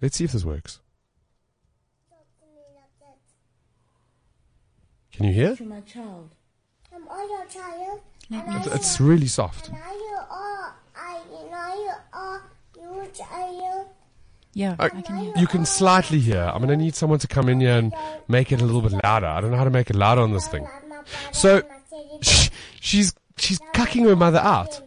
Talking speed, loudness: 130 wpm, -21 LUFS